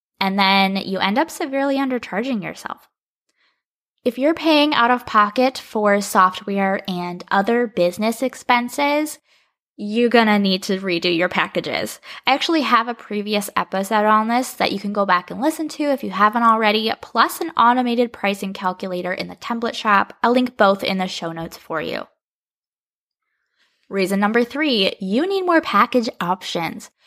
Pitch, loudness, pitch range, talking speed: 220 Hz, -19 LUFS, 195-255 Hz, 160 wpm